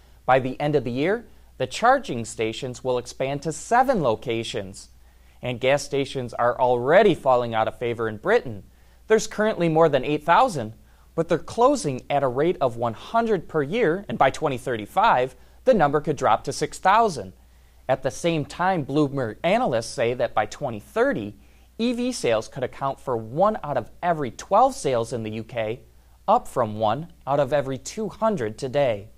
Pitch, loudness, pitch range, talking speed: 135 Hz, -23 LUFS, 115-170 Hz, 165 wpm